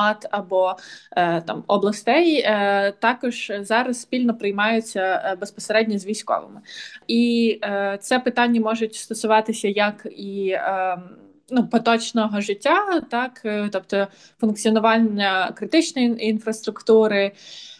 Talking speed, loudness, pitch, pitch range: 85 wpm, -21 LUFS, 220 Hz, 200-235 Hz